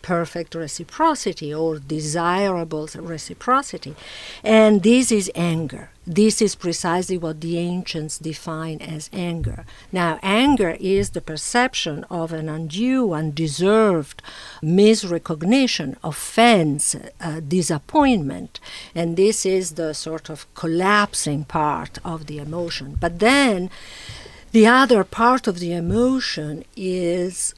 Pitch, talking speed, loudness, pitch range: 170 Hz, 110 wpm, -20 LUFS, 160-210 Hz